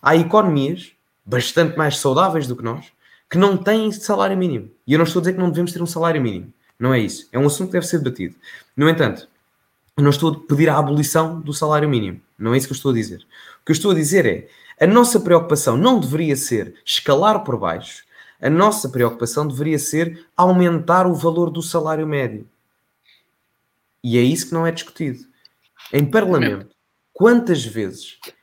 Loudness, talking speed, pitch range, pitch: -18 LUFS, 195 wpm, 130-175 Hz, 155 Hz